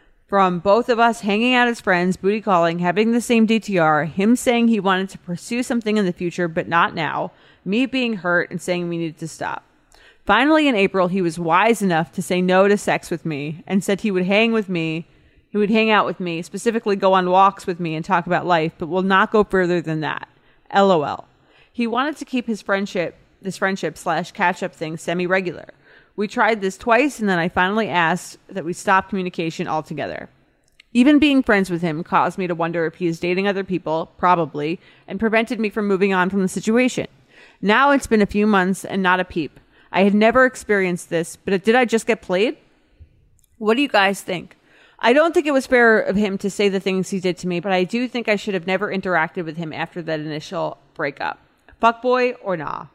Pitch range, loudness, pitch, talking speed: 175-220 Hz, -19 LUFS, 190 Hz, 225 wpm